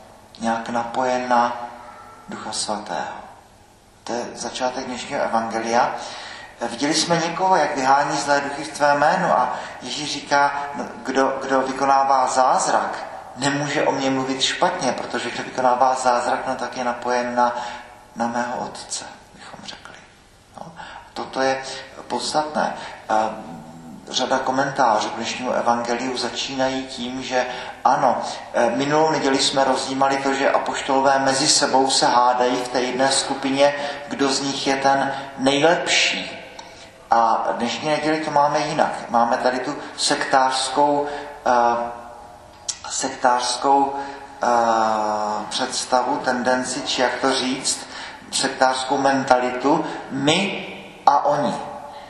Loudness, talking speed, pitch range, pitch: -20 LUFS, 120 wpm, 120-140 Hz, 130 Hz